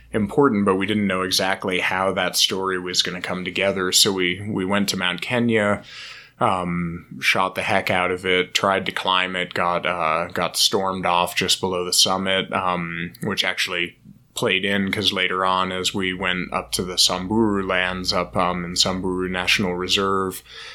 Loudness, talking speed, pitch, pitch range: -20 LUFS, 180 wpm, 95 Hz, 90-95 Hz